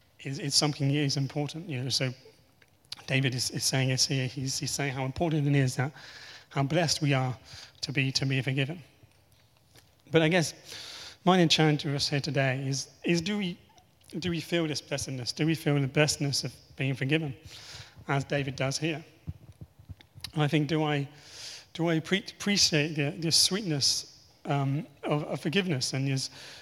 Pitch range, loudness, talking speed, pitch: 130-155 Hz, -28 LUFS, 180 wpm, 140 Hz